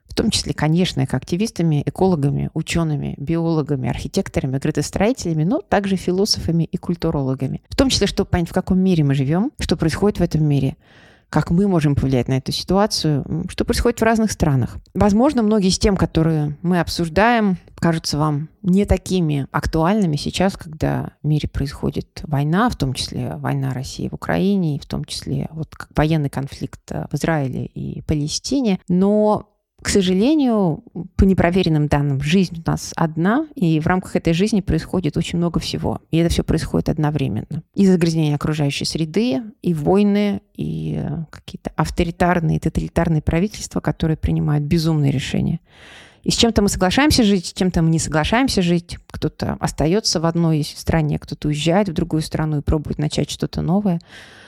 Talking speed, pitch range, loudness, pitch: 160 wpm, 150-190 Hz, -19 LUFS, 165 Hz